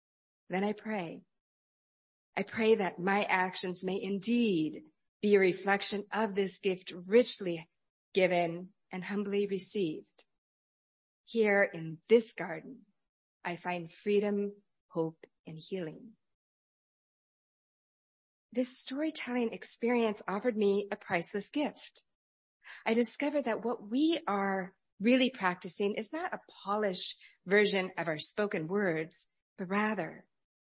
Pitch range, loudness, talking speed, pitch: 185-225 Hz, -32 LUFS, 115 wpm, 200 Hz